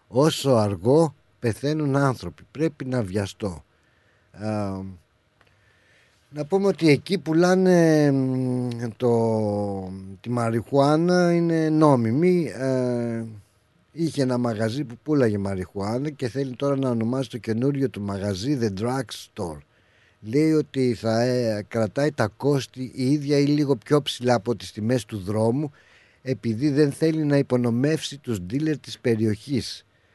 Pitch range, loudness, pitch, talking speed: 110-145 Hz, -23 LUFS, 125 Hz, 125 wpm